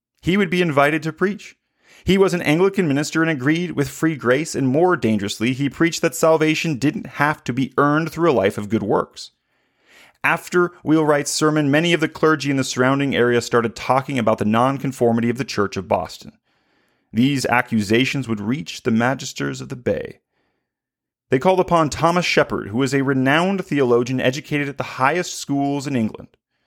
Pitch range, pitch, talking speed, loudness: 125-160 Hz, 140 Hz, 180 wpm, -19 LUFS